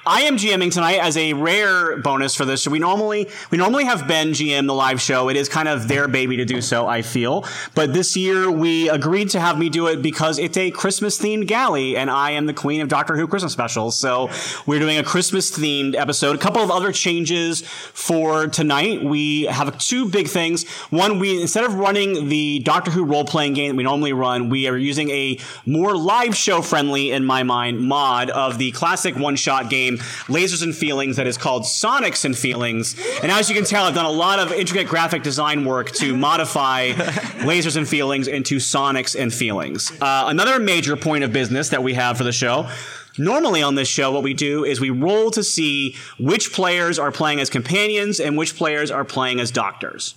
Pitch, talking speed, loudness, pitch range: 150 Hz, 210 wpm, -19 LUFS, 135-175 Hz